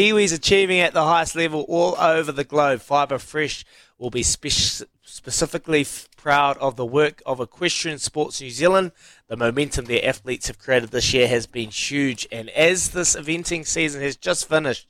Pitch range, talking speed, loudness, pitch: 125-165 Hz, 180 wpm, -21 LUFS, 145 Hz